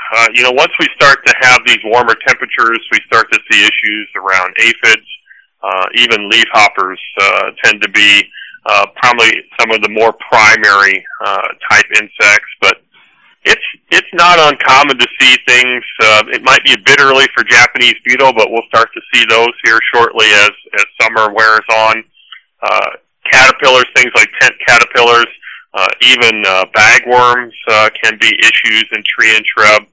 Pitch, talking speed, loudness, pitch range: 115 Hz, 170 wpm, -7 LUFS, 110-125 Hz